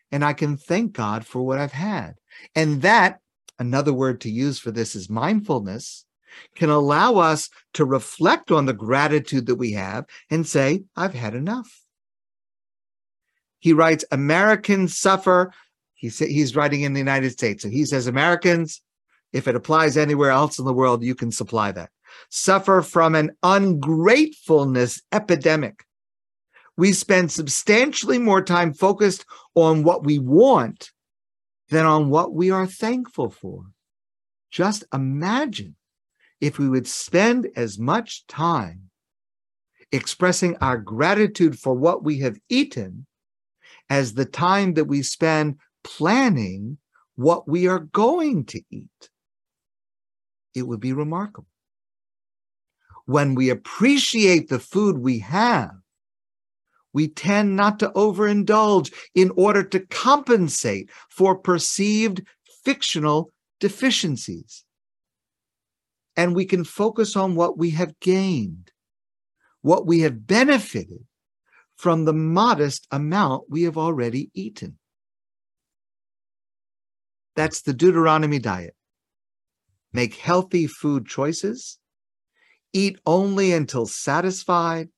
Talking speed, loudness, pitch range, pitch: 120 wpm, -20 LUFS, 135-195 Hz, 160 Hz